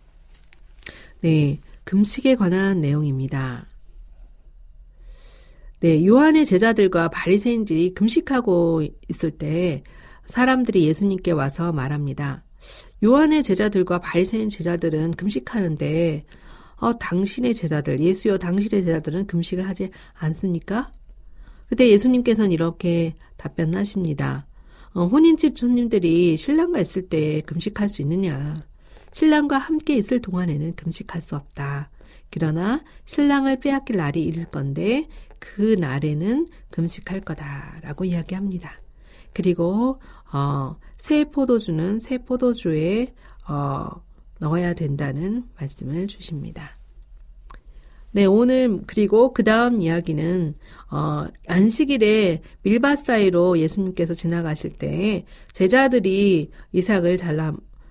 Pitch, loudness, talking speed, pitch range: 180 Hz, -21 LUFS, 260 characters per minute, 160-220 Hz